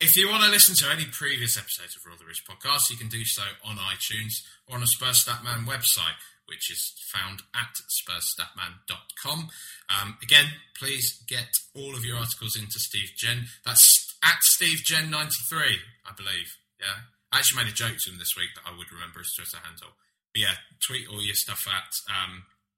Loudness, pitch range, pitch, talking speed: -23 LUFS, 100-135 Hz, 115 Hz, 180 wpm